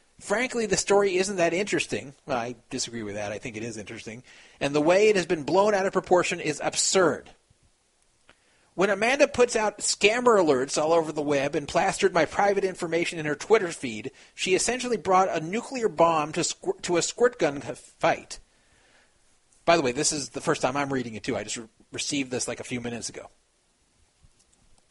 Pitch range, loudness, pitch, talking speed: 140-200 Hz, -25 LUFS, 170 Hz, 200 wpm